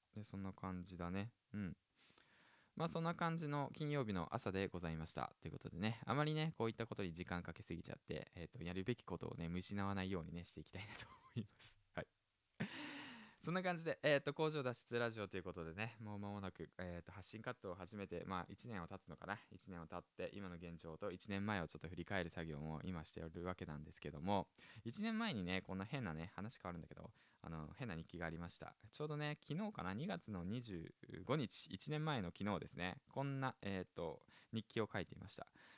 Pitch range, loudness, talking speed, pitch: 85-120 Hz, -47 LUFS, 410 characters per minute, 100 Hz